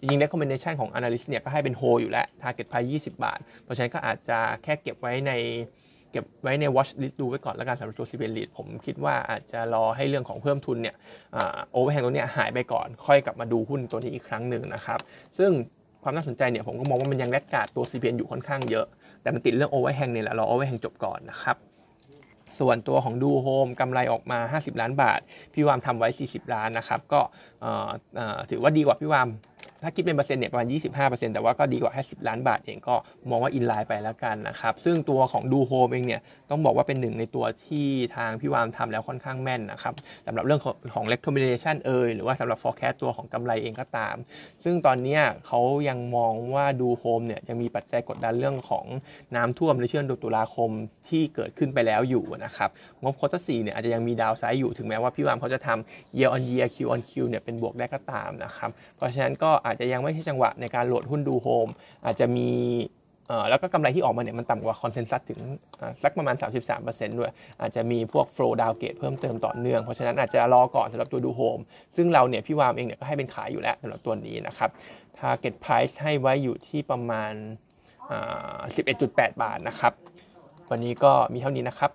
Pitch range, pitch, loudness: 115-140 Hz, 125 Hz, -27 LUFS